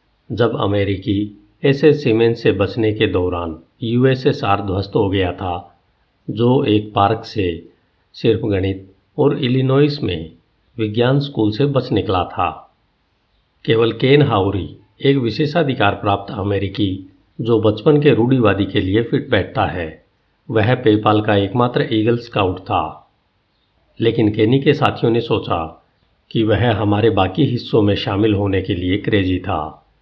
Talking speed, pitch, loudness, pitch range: 140 wpm, 110 Hz, -17 LUFS, 100-120 Hz